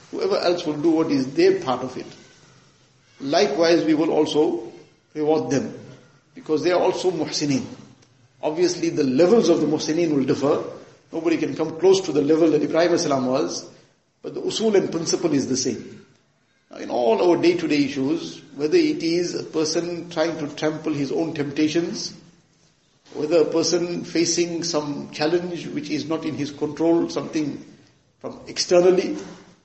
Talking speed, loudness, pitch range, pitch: 160 wpm, -22 LUFS, 155-185 Hz, 165 Hz